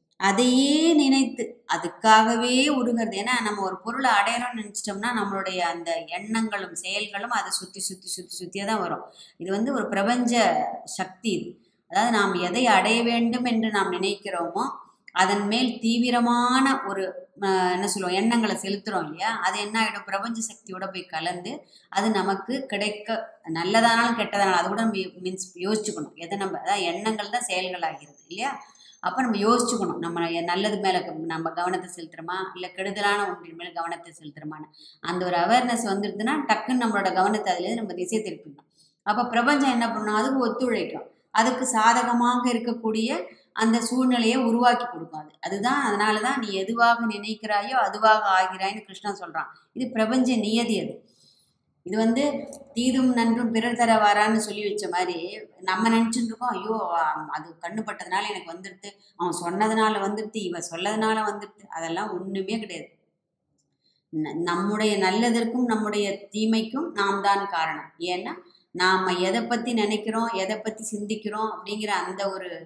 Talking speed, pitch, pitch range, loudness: 135 wpm, 210 Hz, 185-235 Hz, -25 LUFS